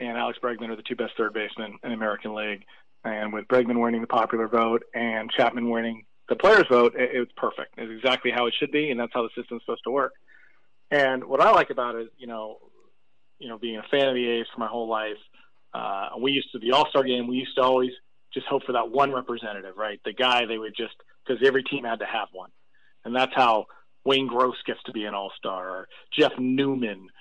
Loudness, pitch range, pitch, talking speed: -25 LUFS, 115-130 Hz, 120 Hz, 240 wpm